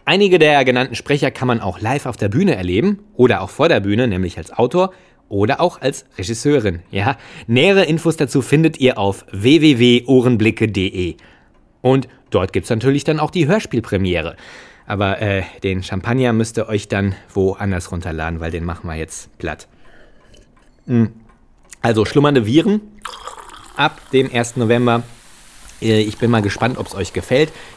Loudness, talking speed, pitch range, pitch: -17 LUFS, 155 wpm, 100-135 Hz, 115 Hz